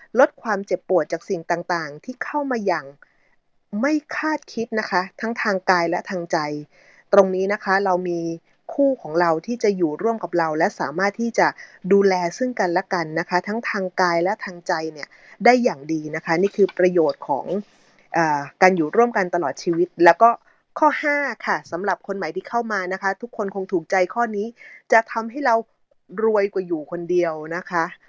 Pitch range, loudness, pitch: 175-225 Hz, -21 LUFS, 190 Hz